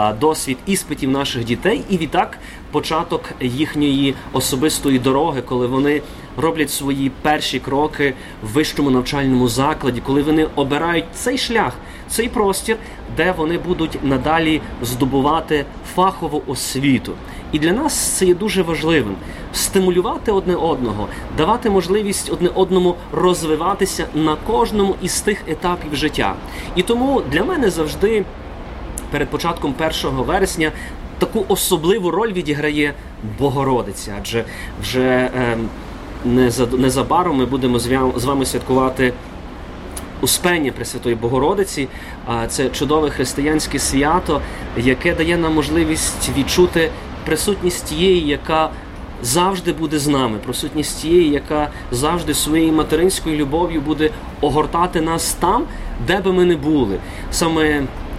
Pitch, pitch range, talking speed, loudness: 150 Hz, 130-170 Hz, 120 wpm, -18 LUFS